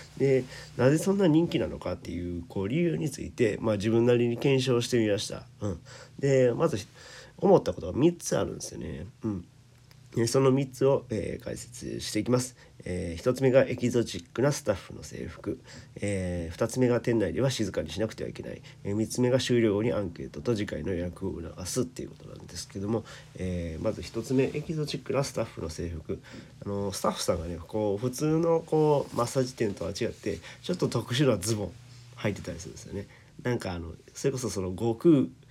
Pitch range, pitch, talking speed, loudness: 100-135 Hz, 120 Hz, 375 characters per minute, -29 LUFS